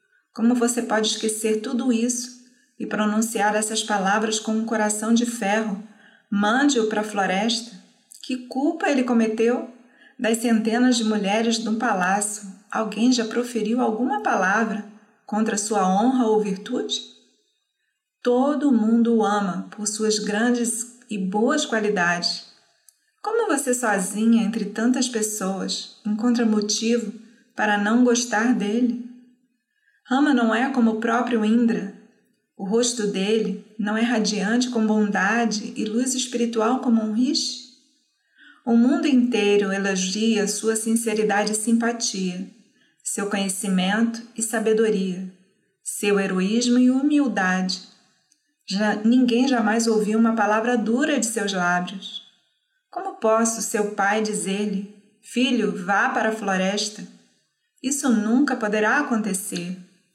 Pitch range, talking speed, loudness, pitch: 210-240 Hz, 120 wpm, -22 LUFS, 220 Hz